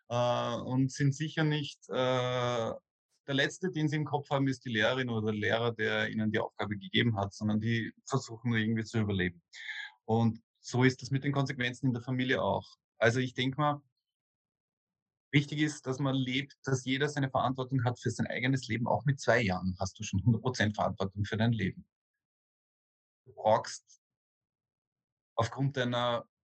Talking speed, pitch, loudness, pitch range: 170 wpm, 125 Hz, -32 LUFS, 110-135 Hz